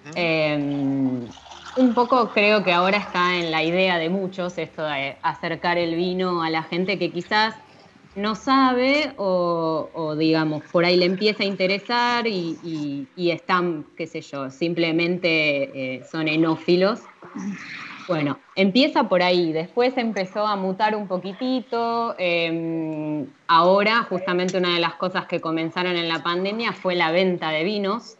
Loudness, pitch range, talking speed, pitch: -22 LUFS, 160-200 Hz, 150 wpm, 180 Hz